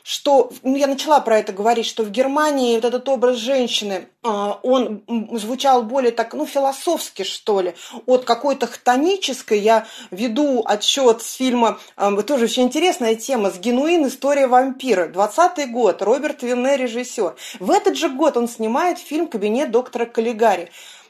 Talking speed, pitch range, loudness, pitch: 150 wpm, 225-275 Hz, -19 LUFS, 250 Hz